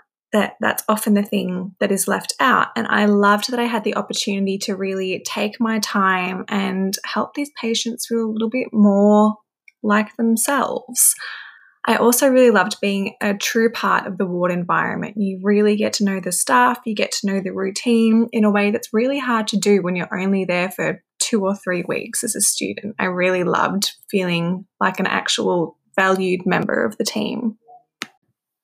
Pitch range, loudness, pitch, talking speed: 190-230 Hz, -19 LUFS, 210 Hz, 190 wpm